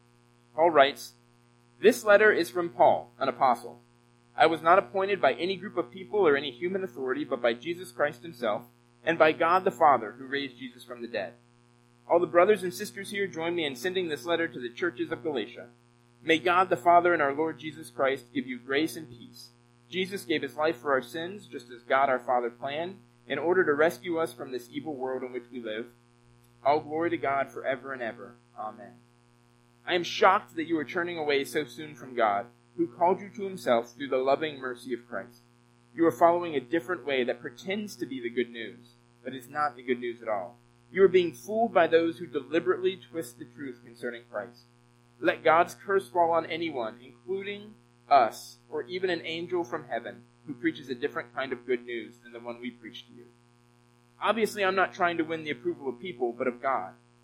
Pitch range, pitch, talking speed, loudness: 120-175 Hz, 140 Hz, 210 wpm, -28 LUFS